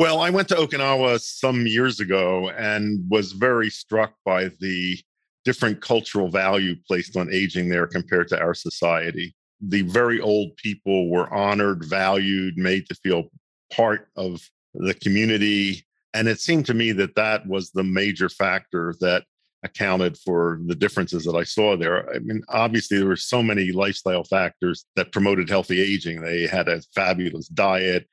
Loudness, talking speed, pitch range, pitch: -22 LUFS, 165 wpm, 90-110 Hz, 100 Hz